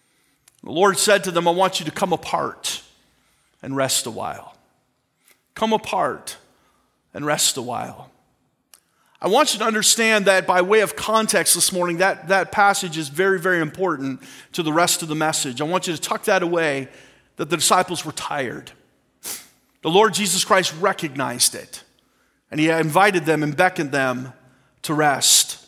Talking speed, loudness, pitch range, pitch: 170 wpm, -19 LUFS, 155-195 Hz, 175 Hz